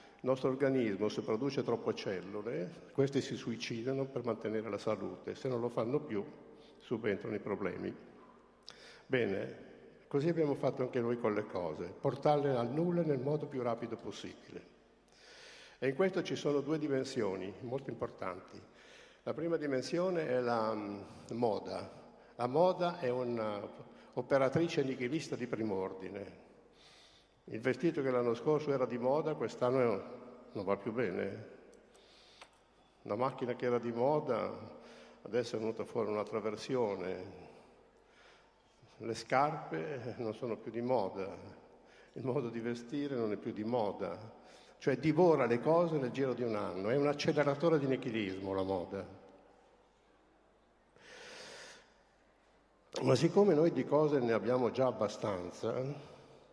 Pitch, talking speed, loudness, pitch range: 125 Hz, 140 wpm, -35 LUFS, 115-145 Hz